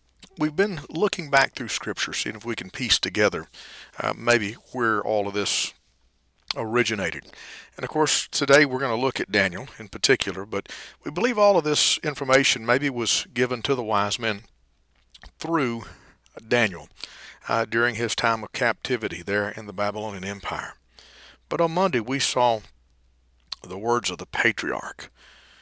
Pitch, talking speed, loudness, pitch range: 115 Hz, 160 wpm, -24 LUFS, 100-135 Hz